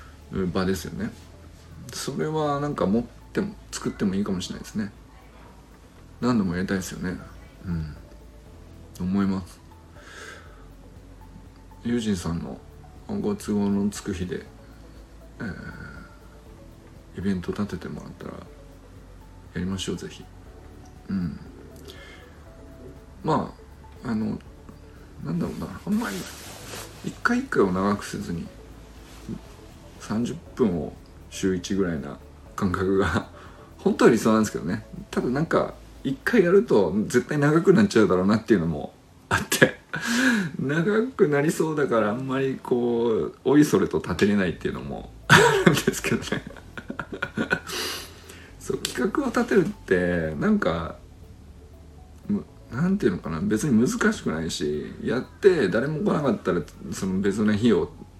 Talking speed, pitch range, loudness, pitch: 255 characters per minute, 85-120 Hz, -25 LUFS, 95 Hz